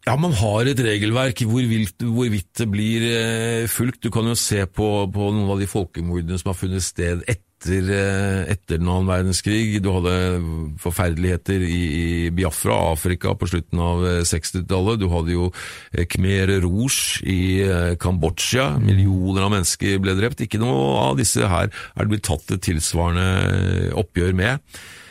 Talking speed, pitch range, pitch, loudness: 155 wpm, 90-105 Hz, 95 Hz, -21 LUFS